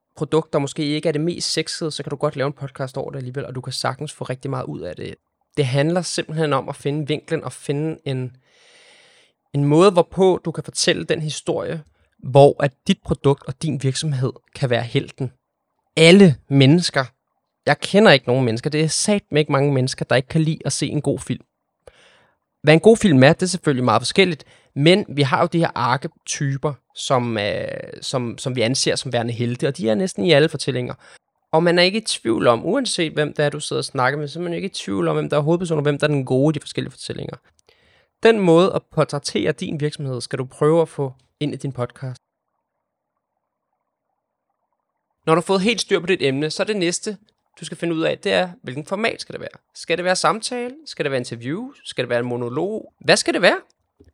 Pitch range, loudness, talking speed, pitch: 135-170 Hz, -19 LUFS, 225 wpm, 150 Hz